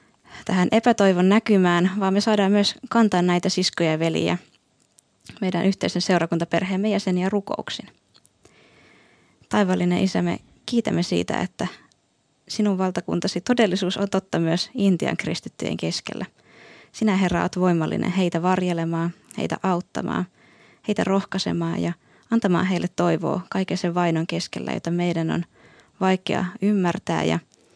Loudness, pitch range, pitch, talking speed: -23 LUFS, 175-200 Hz, 185 Hz, 120 wpm